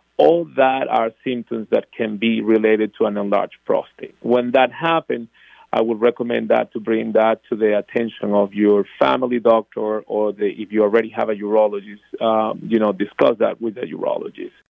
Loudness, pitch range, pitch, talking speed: -19 LUFS, 105-120 Hz, 110 Hz, 185 wpm